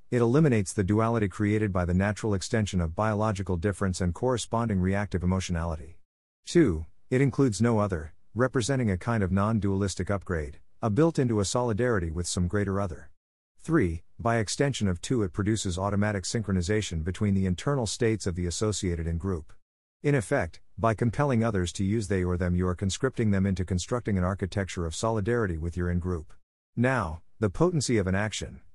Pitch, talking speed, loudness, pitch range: 100 Hz, 175 wpm, -28 LUFS, 90-115 Hz